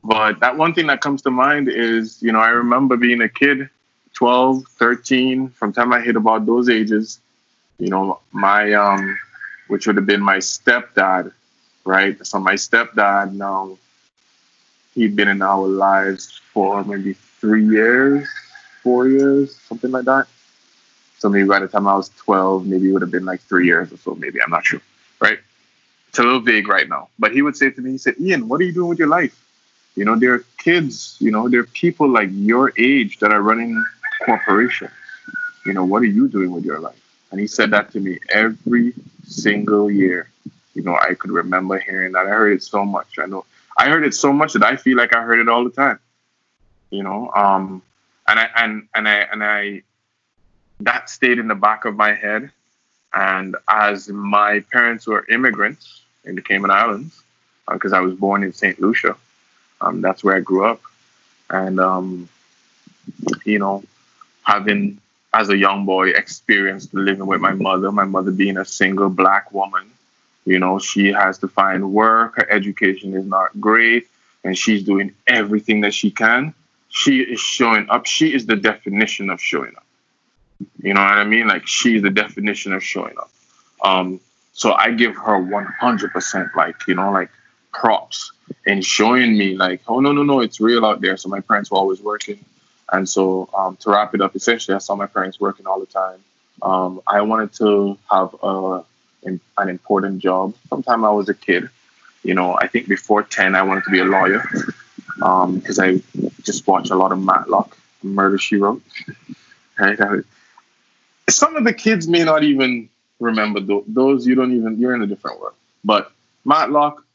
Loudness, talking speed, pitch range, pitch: -17 LUFS, 190 wpm, 95-120 Hz, 105 Hz